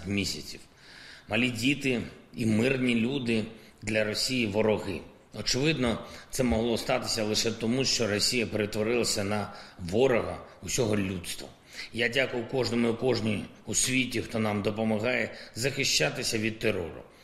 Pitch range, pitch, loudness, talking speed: 105-125 Hz, 110 Hz, -28 LUFS, 120 wpm